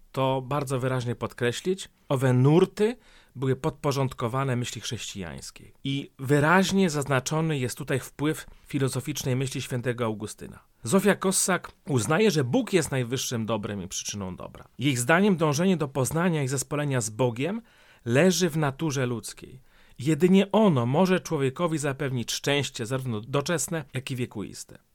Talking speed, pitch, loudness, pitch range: 130 wpm, 140 Hz, -26 LUFS, 125-165 Hz